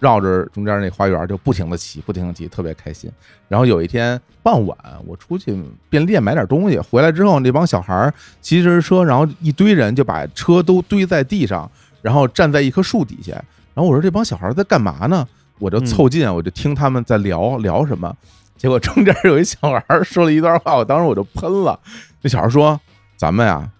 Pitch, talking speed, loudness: 130 Hz, 310 characters per minute, -16 LUFS